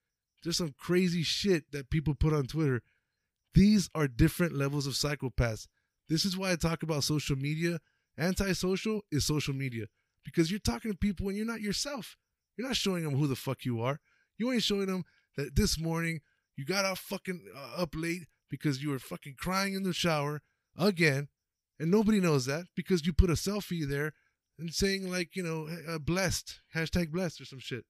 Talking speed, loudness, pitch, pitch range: 190 wpm, -31 LUFS, 165 Hz, 145-185 Hz